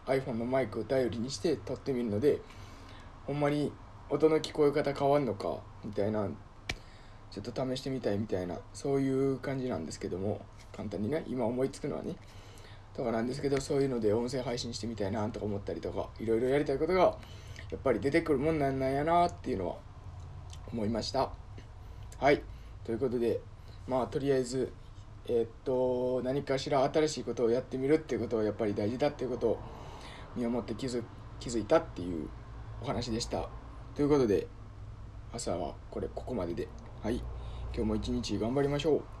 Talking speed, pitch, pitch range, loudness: 390 characters per minute, 115 Hz, 105-135 Hz, -33 LUFS